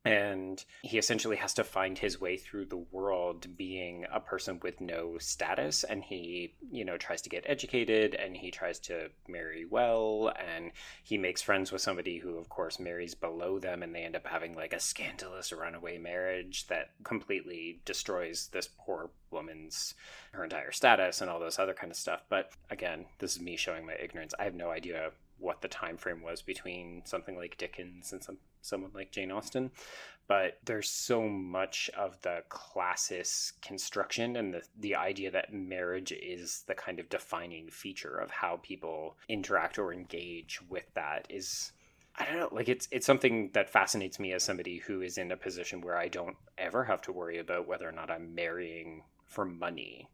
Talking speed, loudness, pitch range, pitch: 190 wpm, -35 LUFS, 85-95 Hz, 90 Hz